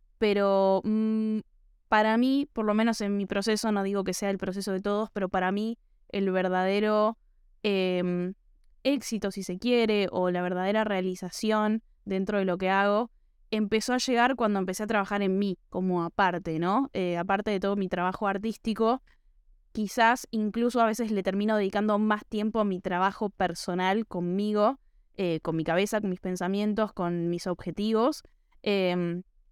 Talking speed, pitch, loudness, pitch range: 165 wpm, 200 Hz, -28 LUFS, 185-220 Hz